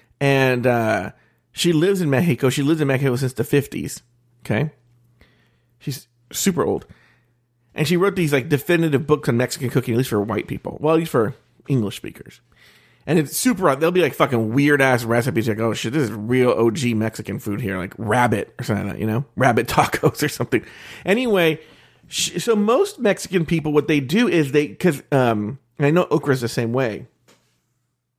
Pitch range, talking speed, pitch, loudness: 120-155 Hz, 190 wpm, 130 Hz, -20 LUFS